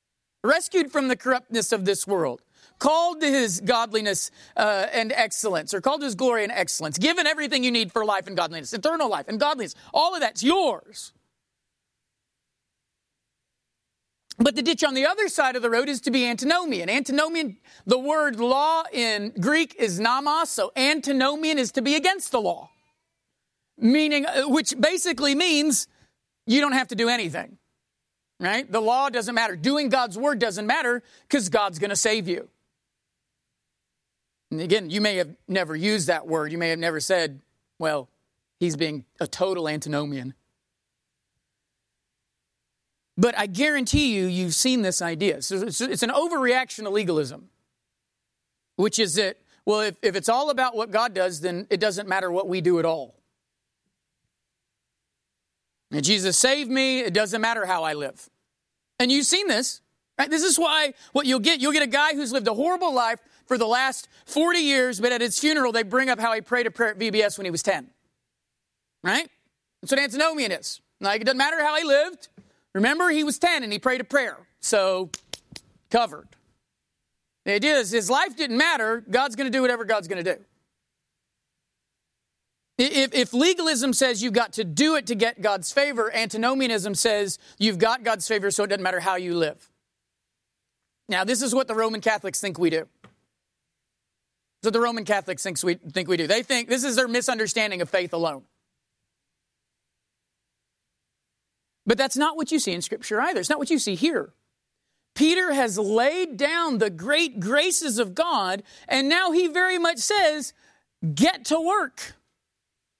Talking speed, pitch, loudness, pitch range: 170 wpm, 240 Hz, -23 LUFS, 200-285 Hz